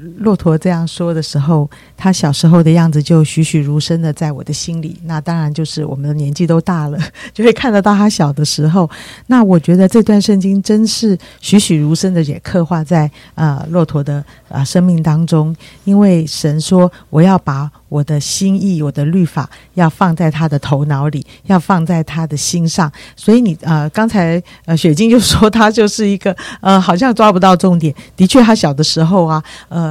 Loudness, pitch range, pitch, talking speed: -12 LUFS, 150-190 Hz, 165 Hz, 285 characters per minute